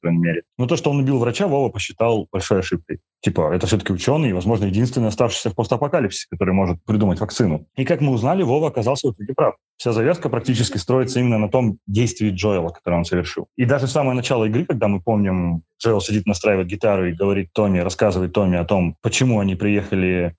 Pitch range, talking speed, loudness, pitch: 95-125 Hz, 205 wpm, -20 LUFS, 110 Hz